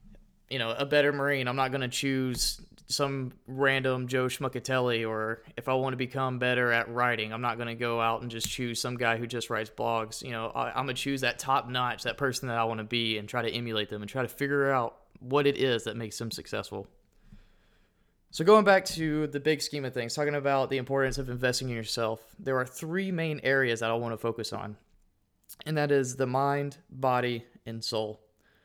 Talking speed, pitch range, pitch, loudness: 225 wpm, 115-135 Hz, 125 Hz, -29 LUFS